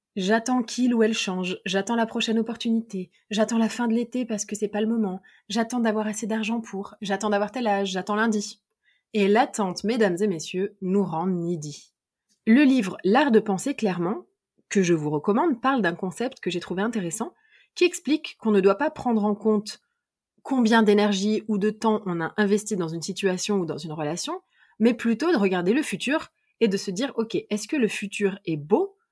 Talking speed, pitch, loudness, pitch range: 200 wpm, 215 Hz, -24 LUFS, 195-230 Hz